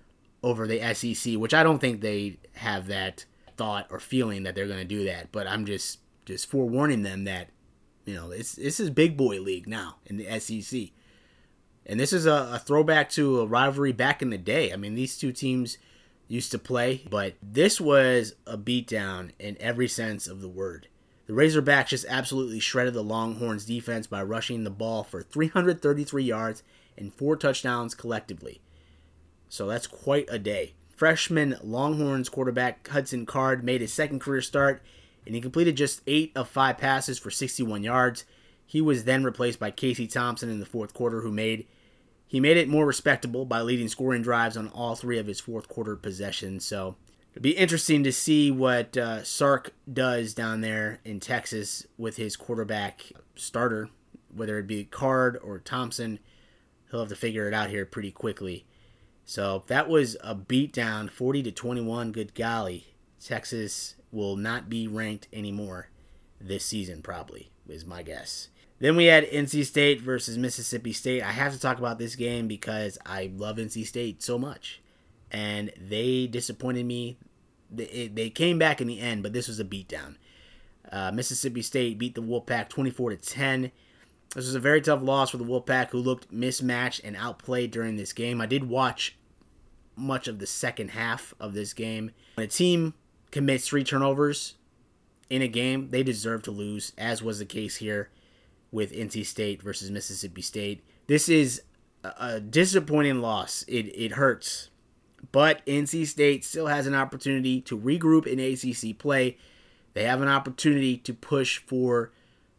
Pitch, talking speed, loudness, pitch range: 120 Hz, 175 wpm, -27 LUFS, 105-130 Hz